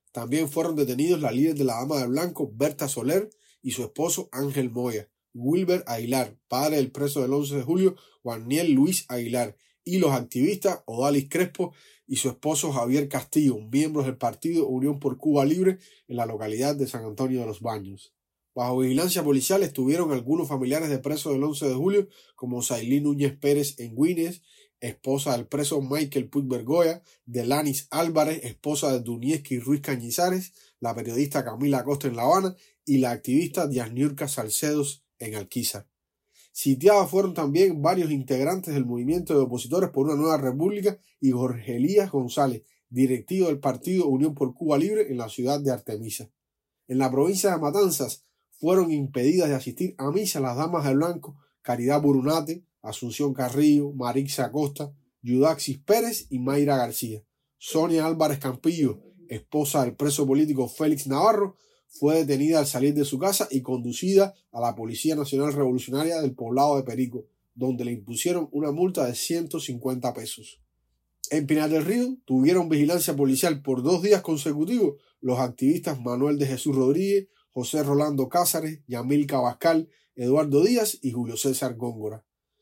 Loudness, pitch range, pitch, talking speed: -25 LUFS, 130-160 Hz, 140 Hz, 160 wpm